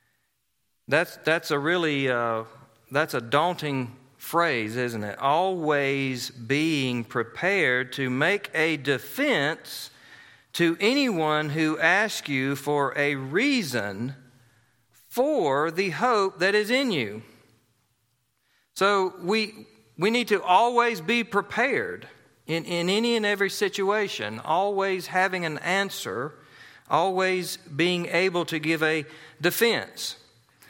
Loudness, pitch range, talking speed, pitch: -25 LUFS, 130-190 Hz, 115 wpm, 160 Hz